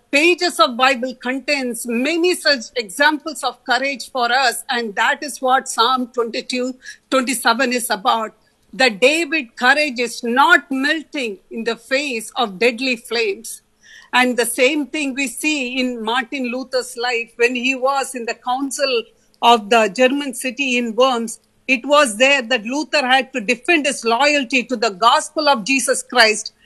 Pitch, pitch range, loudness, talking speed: 255 Hz, 240-280 Hz, -17 LUFS, 160 wpm